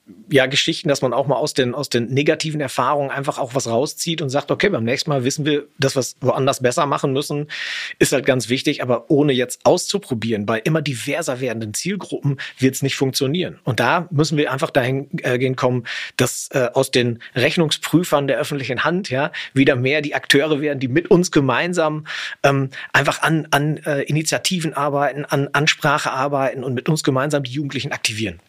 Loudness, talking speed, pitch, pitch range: -19 LUFS, 195 wpm, 140 Hz, 130-155 Hz